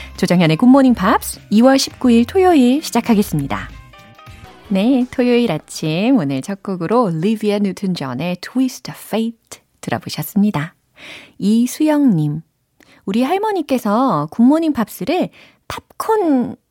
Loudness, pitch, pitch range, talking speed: -16 LUFS, 225 Hz, 180-260 Hz, 260 characters per minute